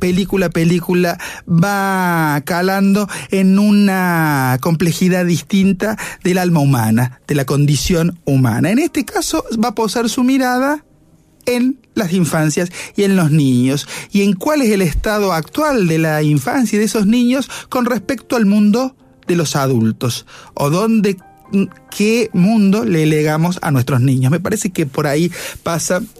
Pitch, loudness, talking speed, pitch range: 185 Hz, -15 LUFS, 150 wpm, 155-215 Hz